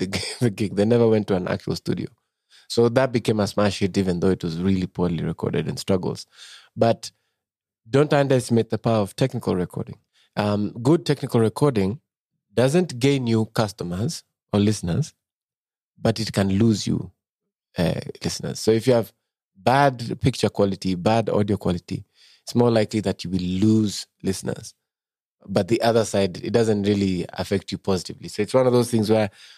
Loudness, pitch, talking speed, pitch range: -22 LUFS, 110 Hz, 170 wpm, 95-115 Hz